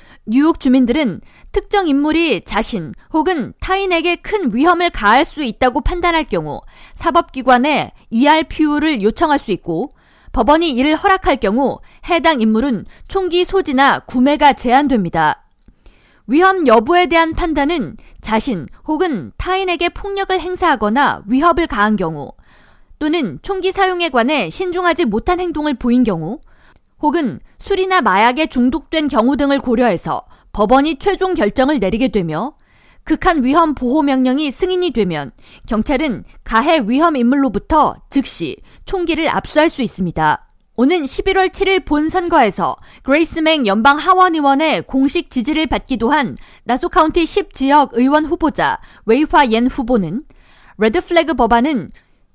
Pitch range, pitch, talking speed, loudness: 245-340 Hz, 295 Hz, 300 characters per minute, -15 LUFS